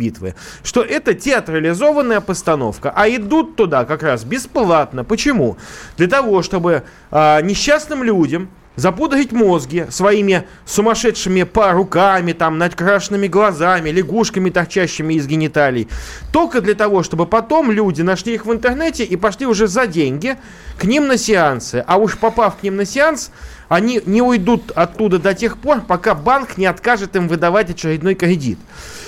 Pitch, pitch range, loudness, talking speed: 200 Hz, 175-230 Hz, -15 LUFS, 145 wpm